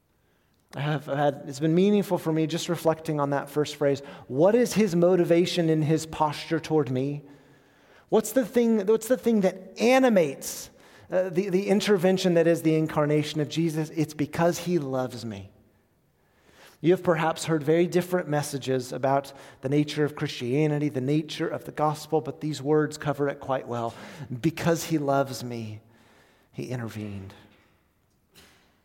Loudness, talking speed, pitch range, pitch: -25 LUFS, 160 wpm, 140-170 Hz, 150 Hz